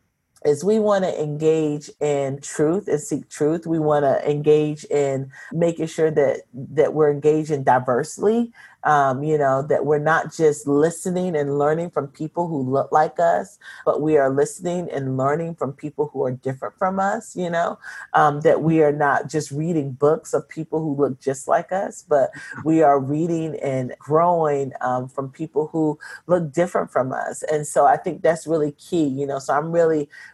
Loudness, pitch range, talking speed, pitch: -21 LUFS, 145-165 Hz, 185 wpm, 150 Hz